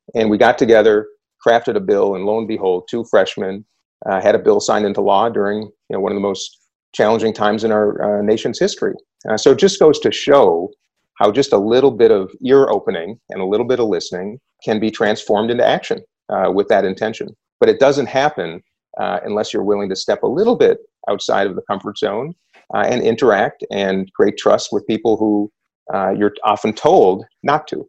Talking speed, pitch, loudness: 210 wpm, 110 Hz, -16 LUFS